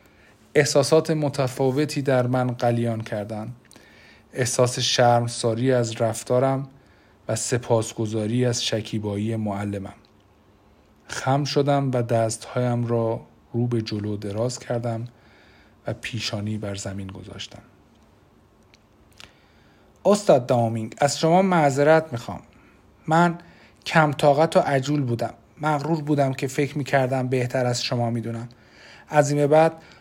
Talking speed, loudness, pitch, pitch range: 105 wpm, -23 LUFS, 120 Hz, 110-140 Hz